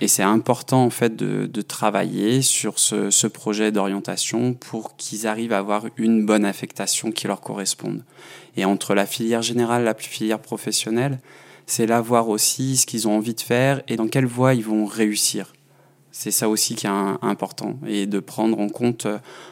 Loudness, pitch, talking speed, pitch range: -21 LUFS, 110 Hz, 190 wpm, 105-120 Hz